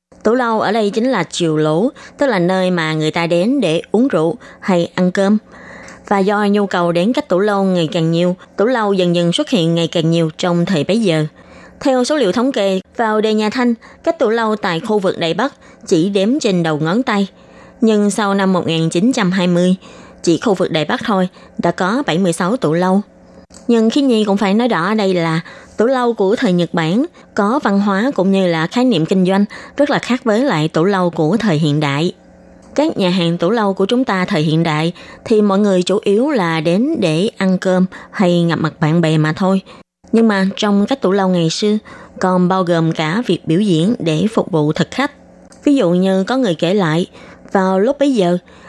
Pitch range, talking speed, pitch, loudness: 170-225 Hz, 220 wpm, 190 Hz, -15 LUFS